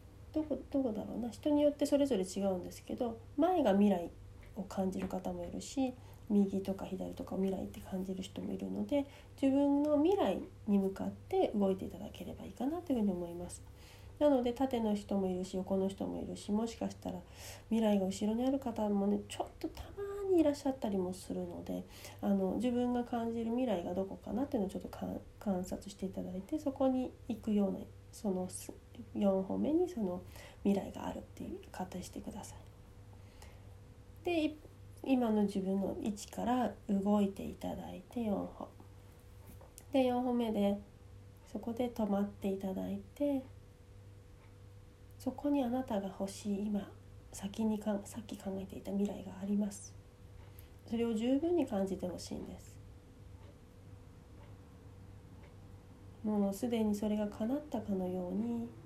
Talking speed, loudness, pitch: 315 characters per minute, -36 LUFS, 195 Hz